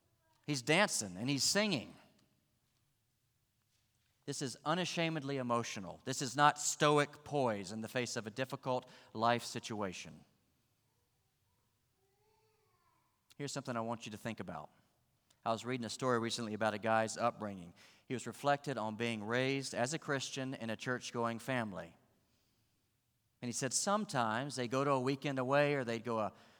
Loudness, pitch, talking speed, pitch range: -36 LUFS, 120 Hz, 150 wpm, 110-135 Hz